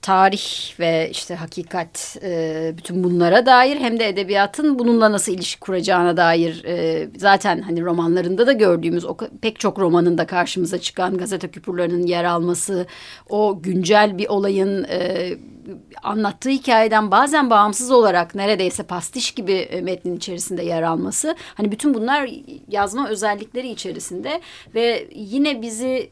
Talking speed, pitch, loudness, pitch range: 125 wpm, 195 Hz, -19 LUFS, 175-225 Hz